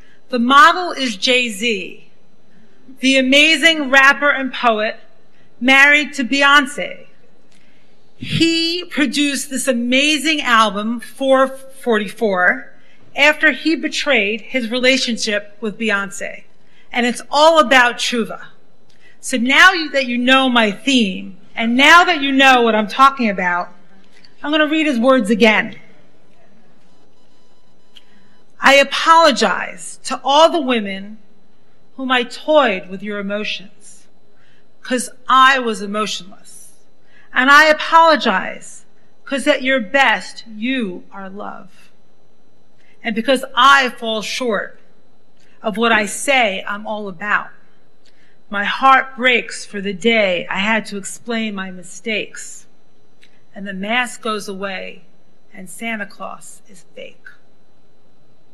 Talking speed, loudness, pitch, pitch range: 115 wpm, -14 LUFS, 245 Hz, 210-275 Hz